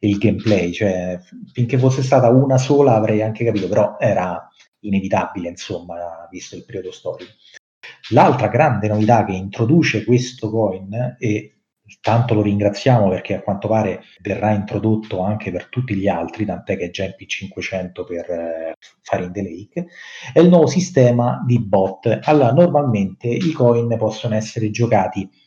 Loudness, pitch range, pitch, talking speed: -18 LUFS, 95-120 Hz, 110 Hz, 155 wpm